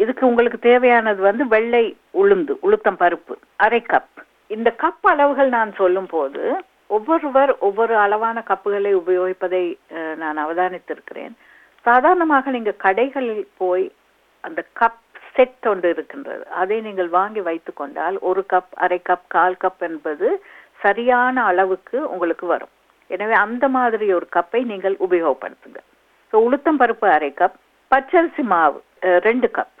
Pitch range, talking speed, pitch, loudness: 185-255 Hz, 125 wpm, 215 Hz, -18 LUFS